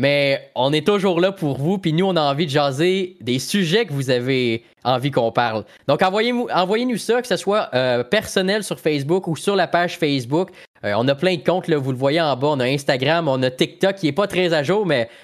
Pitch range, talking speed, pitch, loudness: 140-190 Hz, 250 wpm, 165 Hz, -19 LUFS